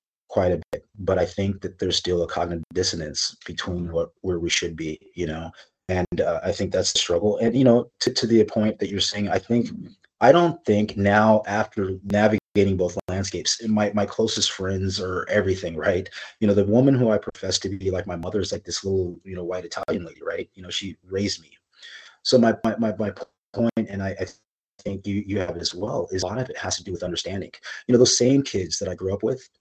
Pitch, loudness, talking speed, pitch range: 100 Hz, -23 LUFS, 235 wpm, 90-110 Hz